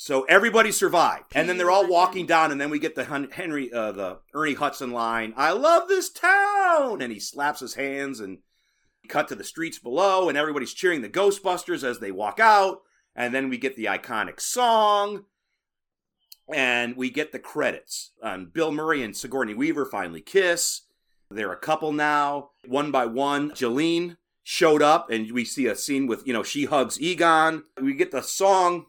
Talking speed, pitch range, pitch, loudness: 185 wpm, 135-190 Hz, 155 Hz, -23 LUFS